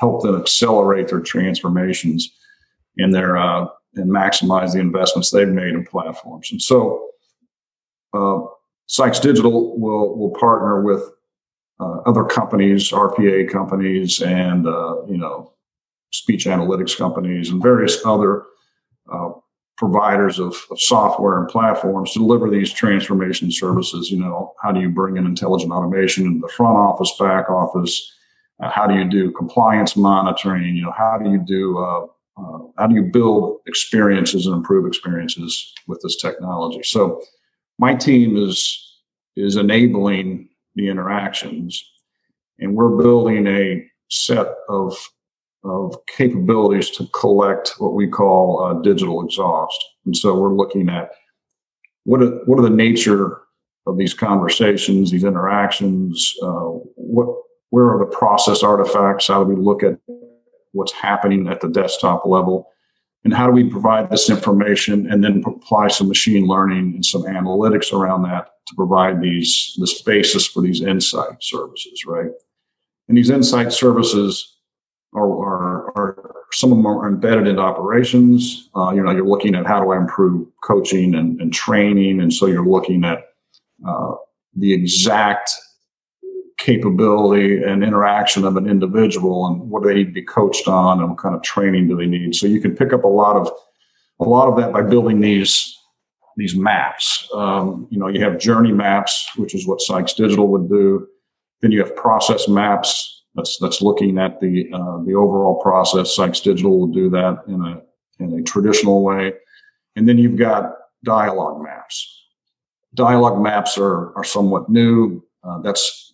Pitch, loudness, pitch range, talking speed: 100 Hz, -16 LUFS, 95-110 Hz, 160 wpm